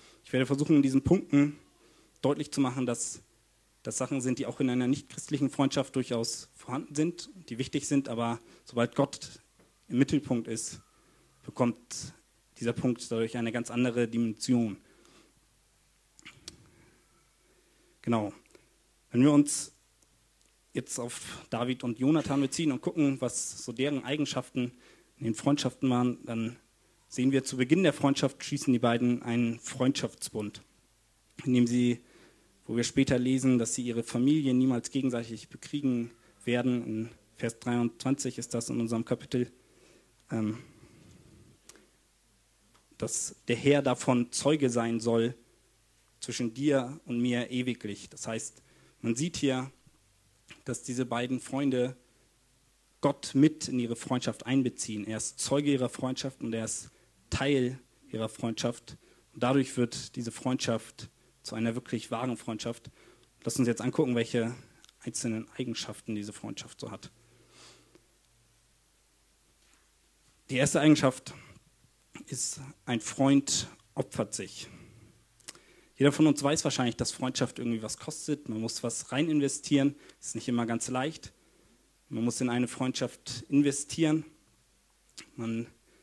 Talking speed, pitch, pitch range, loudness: 135 wpm, 125 Hz, 115-135 Hz, -30 LUFS